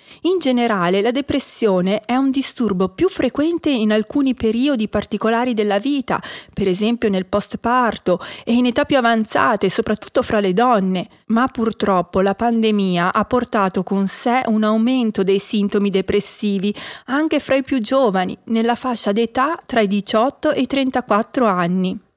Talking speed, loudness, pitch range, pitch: 155 wpm, -18 LUFS, 205-255 Hz, 225 Hz